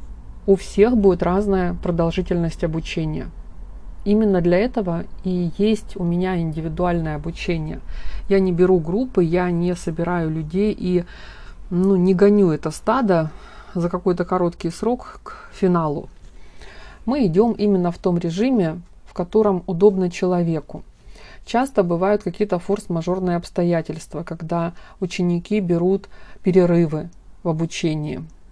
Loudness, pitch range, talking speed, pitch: -20 LUFS, 165-195 Hz, 120 wpm, 180 Hz